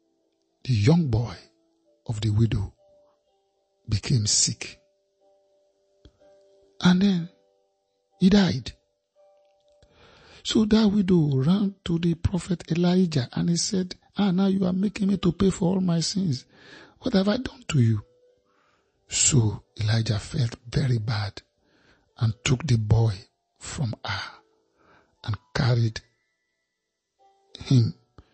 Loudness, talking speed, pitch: -24 LUFS, 115 wpm, 170 Hz